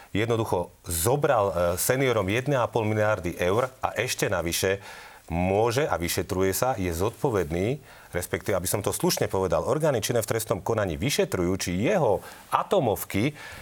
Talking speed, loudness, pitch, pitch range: 130 wpm, -26 LUFS, 95 Hz, 90-110 Hz